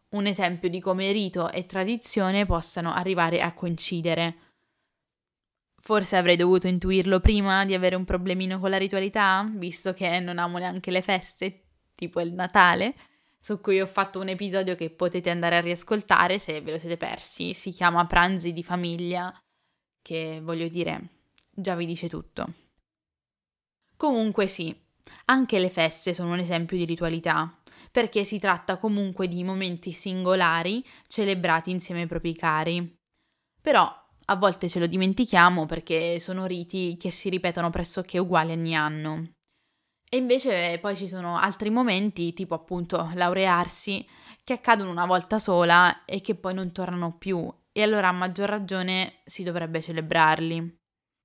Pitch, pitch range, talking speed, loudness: 180 Hz, 170-190 Hz, 150 wpm, -25 LUFS